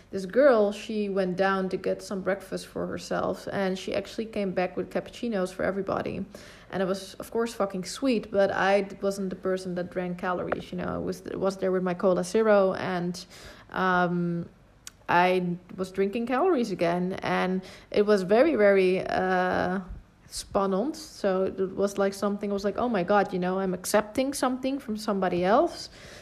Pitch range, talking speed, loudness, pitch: 185-205 Hz, 185 wpm, -27 LUFS, 195 Hz